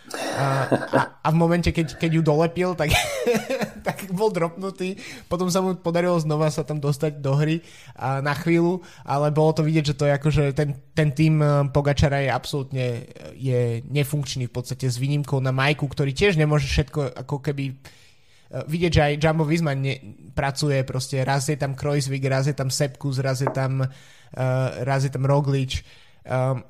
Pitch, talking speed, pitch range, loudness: 145 Hz, 165 wpm, 135-160 Hz, -23 LUFS